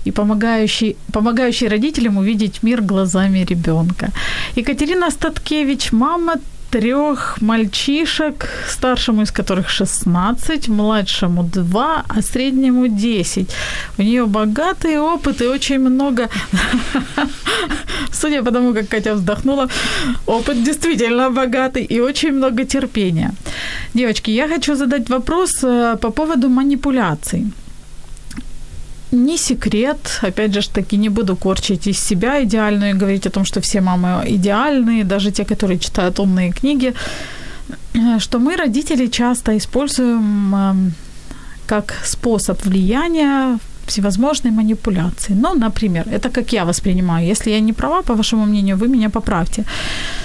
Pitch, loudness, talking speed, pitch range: 225 Hz, -16 LUFS, 120 wpm, 205-260 Hz